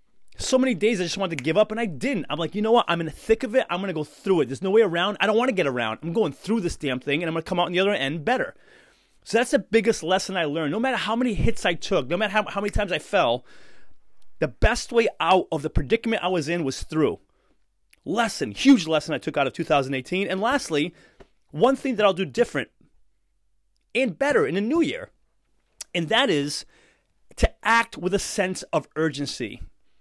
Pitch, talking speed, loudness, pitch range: 190 Hz, 245 wpm, -24 LUFS, 160-230 Hz